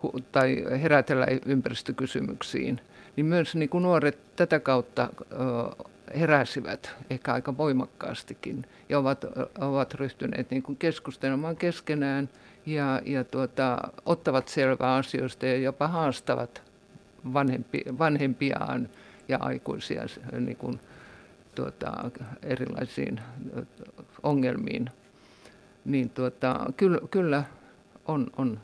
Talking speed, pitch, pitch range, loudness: 90 wpm, 135 Hz, 130-150 Hz, -29 LUFS